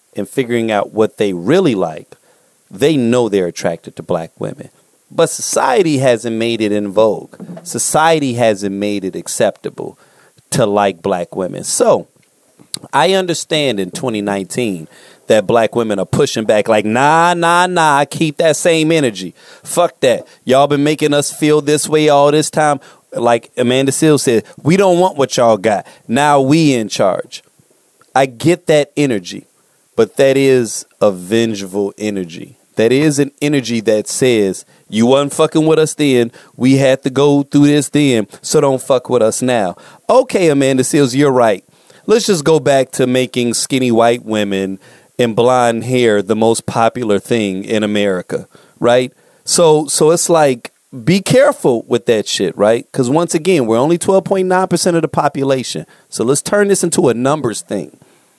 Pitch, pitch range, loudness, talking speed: 135 Hz, 115-155 Hz, -13 LUFS, 165 wpm